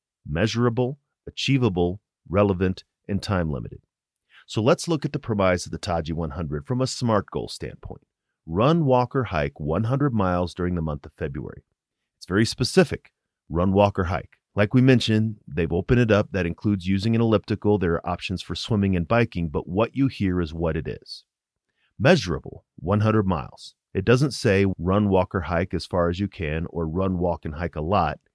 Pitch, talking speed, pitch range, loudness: 95 Hz, 185 wpm, 85-110 Hz, -24 LUFS